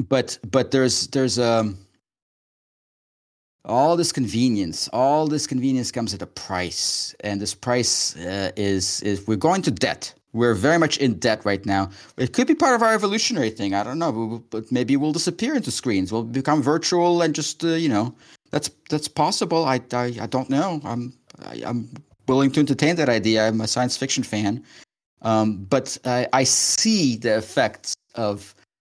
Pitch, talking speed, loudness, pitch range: 125 Hz, 185 wpm, -22 LUFS, 110-150 Hz